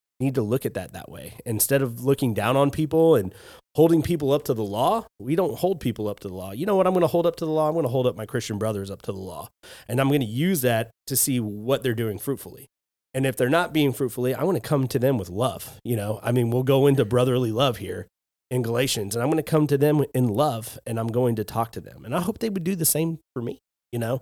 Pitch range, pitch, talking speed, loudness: 115-150 Hz, 130 Hz, 290 wpm, -24 LUFS